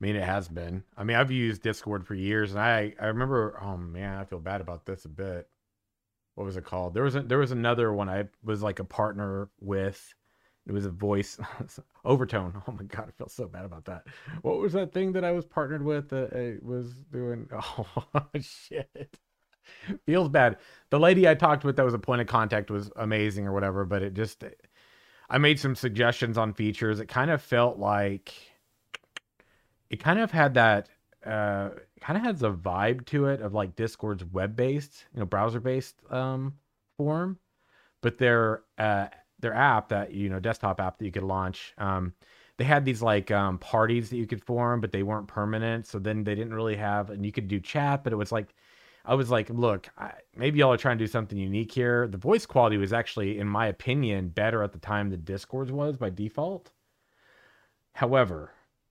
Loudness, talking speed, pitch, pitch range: -28 LUFS, 205 wpm, 110 Hz, 100-125 Hz